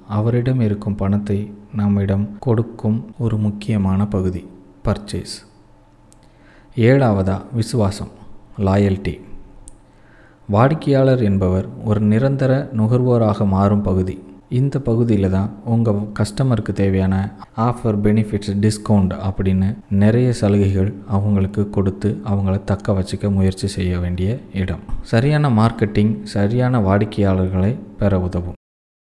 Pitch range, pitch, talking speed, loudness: 95-110 Hz, 105 Hz, 95 wpm, -18 LUFS